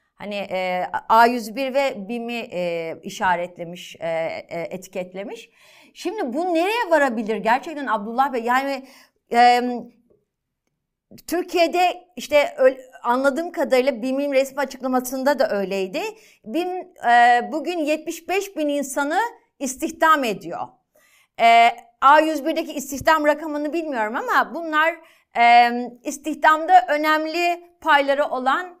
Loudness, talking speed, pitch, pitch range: -20 LUFS, 100 wpm, 280 Hz, 235-320 Hz